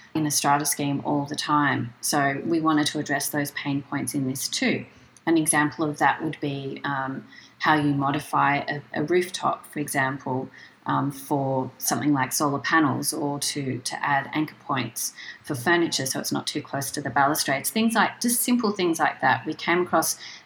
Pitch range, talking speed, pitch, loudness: 140-155 Hz, 190 wpm, 145 Hz, -24 LUFS